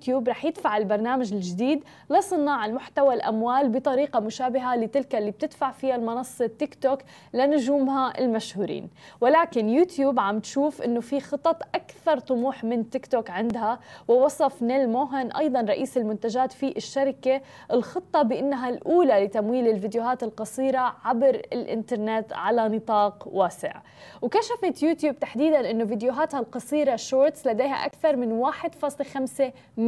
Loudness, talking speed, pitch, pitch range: -25 LUFS, 125 wpm, 260 Hz, 235-285 Hz